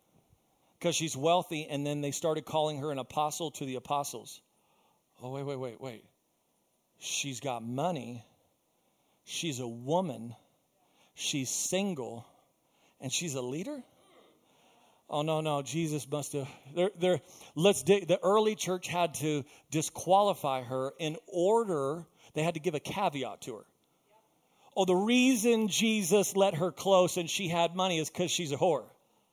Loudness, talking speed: -31 LUFS, 145 wpm